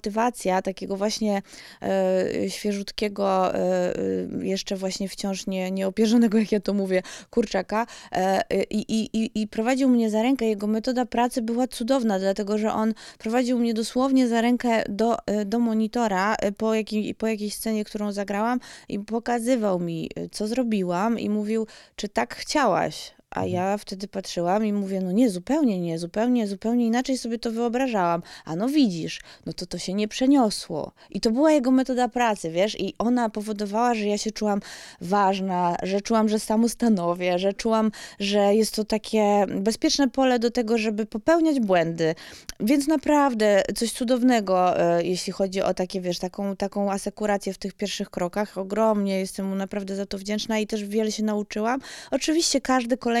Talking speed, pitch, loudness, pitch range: 160 wpm, 215 Hz, -24 LUFS, 195-235 Hz